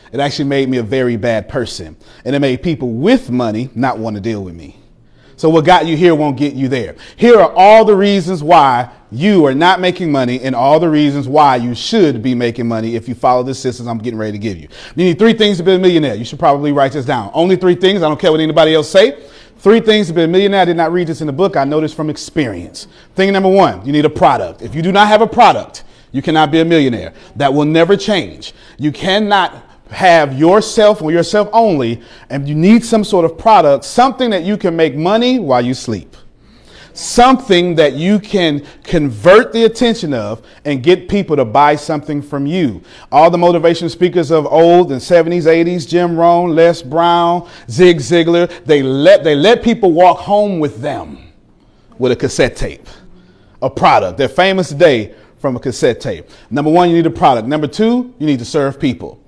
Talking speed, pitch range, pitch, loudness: 220 wpm, 135-185 Hz, 160 Hz, -12 LUFS